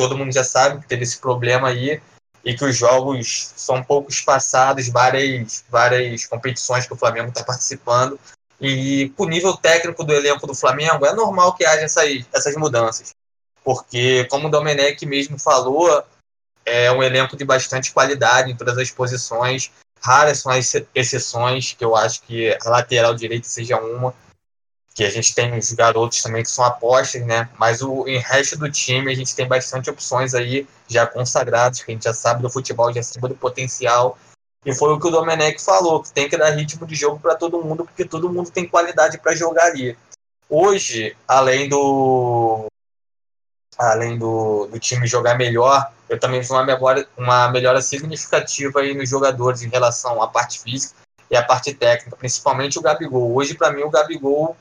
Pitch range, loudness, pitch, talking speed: 120-145 Hz, -18 LUFS, 130 Hz, 185 wpm